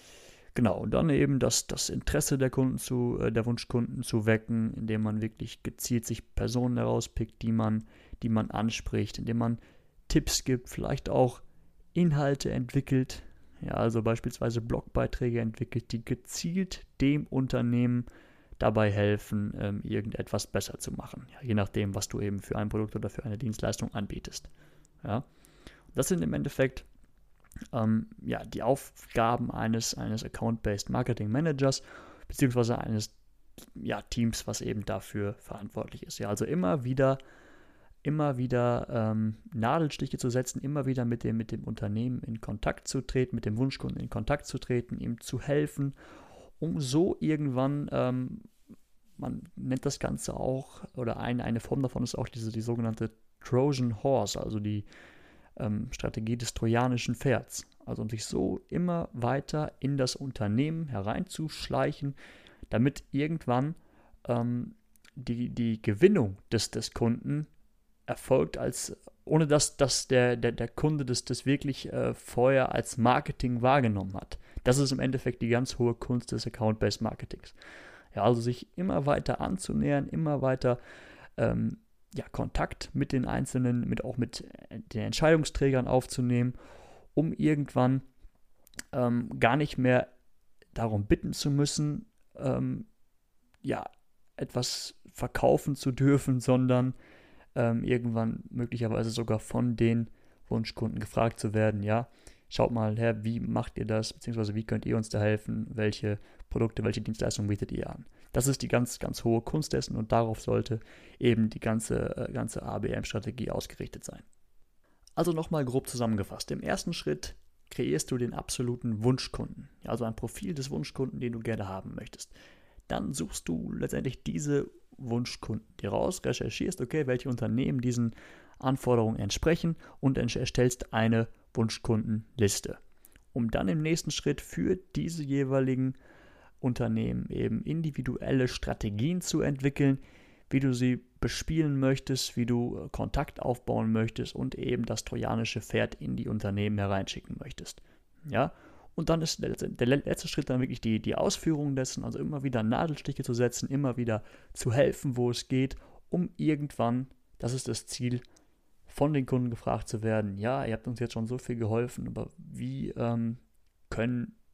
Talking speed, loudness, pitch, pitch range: 150 wpm, -31 LUFS, 120 Hz, 110-135 Hz